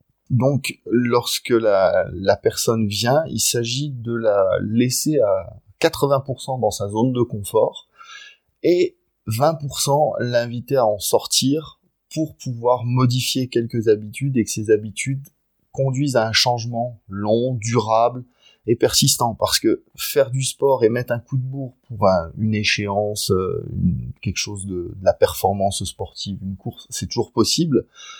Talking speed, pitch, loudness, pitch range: 145 wpm, 120 Hz, -20 LUFS, 110-135 Hz